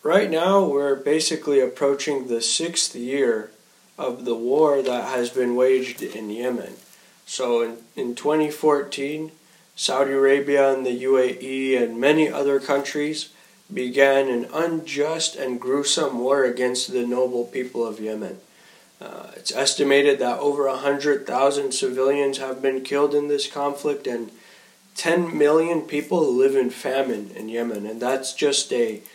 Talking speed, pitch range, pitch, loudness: 145 wpm, 125-150 Hz, 140 Hz, -22 LUFS